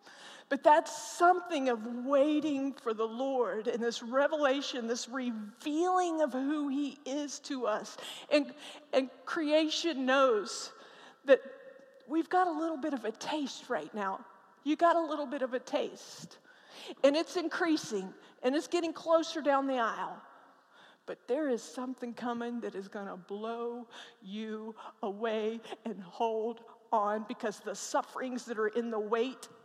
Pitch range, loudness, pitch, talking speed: 230-300 Hz, -33 LUFS, 265 Hz, 150 wpm